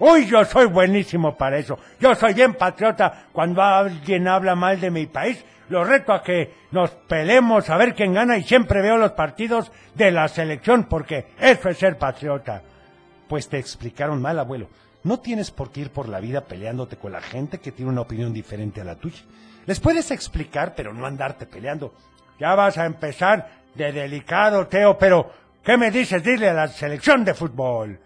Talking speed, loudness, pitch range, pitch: 190 wpm, -19 LUFS, 135-205 Hz, 165 Hz